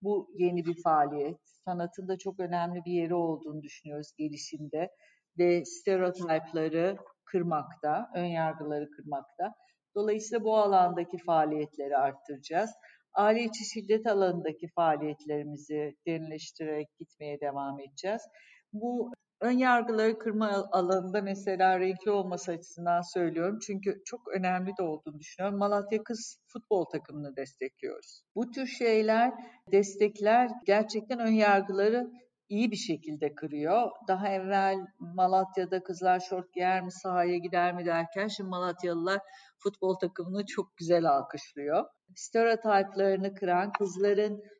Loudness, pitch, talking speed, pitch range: -30 LUFS, 185 Hz, 115 wpm, 165-210 Hz